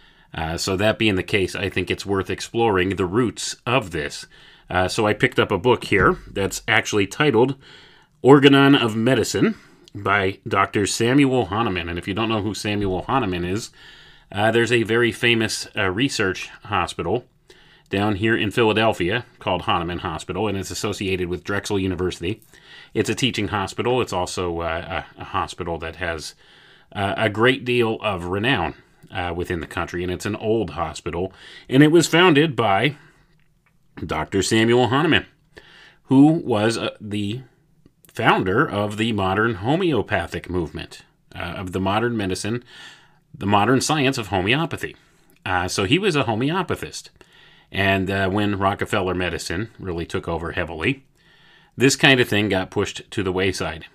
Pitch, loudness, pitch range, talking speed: 105 Hz, -21 LUFS, 95-125 Hz, 160 wpm